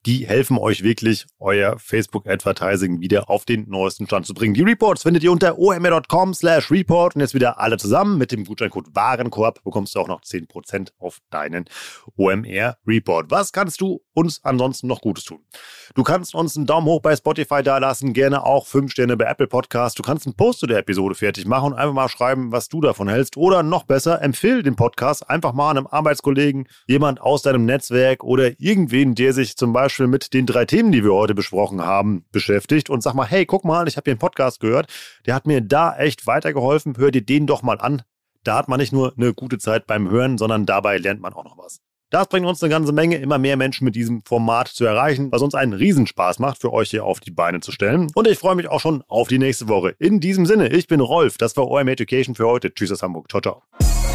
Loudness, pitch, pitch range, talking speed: -18 LUFS, 130 Hz, 110-150 Hz, 225 wpm